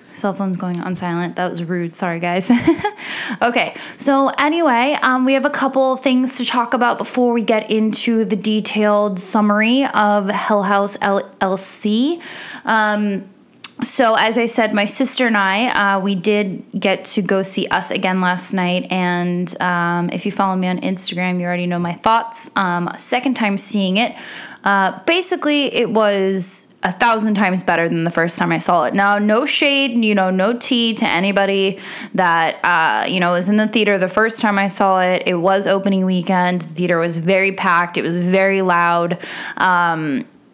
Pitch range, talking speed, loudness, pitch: 185-230 Hz, 180 wpm, -16 LUFS, 200 Hz